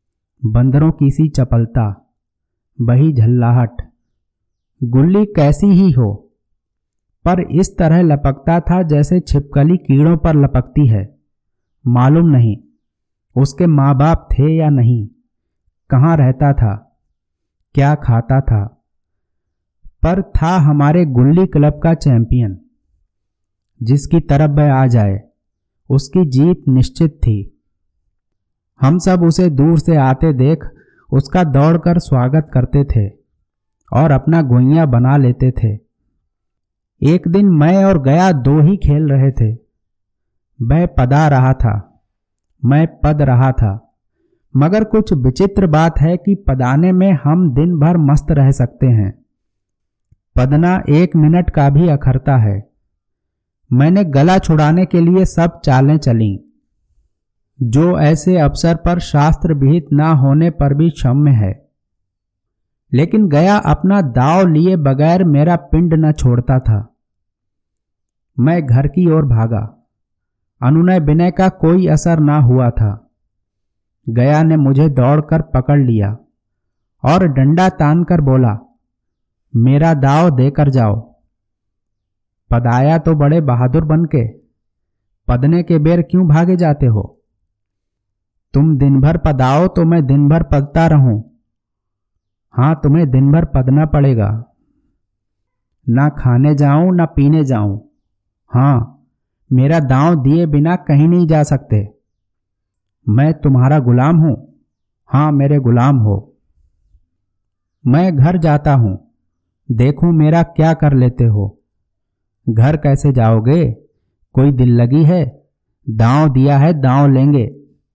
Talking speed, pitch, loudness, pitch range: 125 wpm, 135 Hz, -12 LUFS, 110-160 Hz